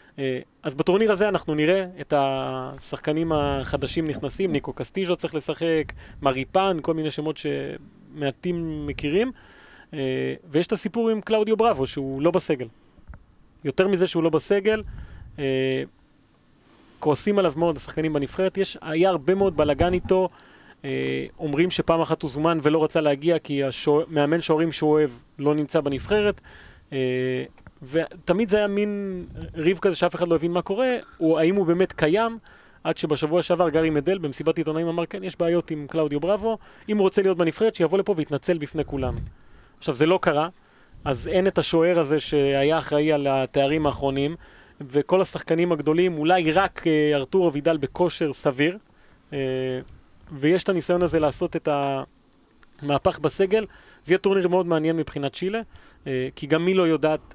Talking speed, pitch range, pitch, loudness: 155 wpm, 145-180 Hz, 160 Hz, -23 LUFS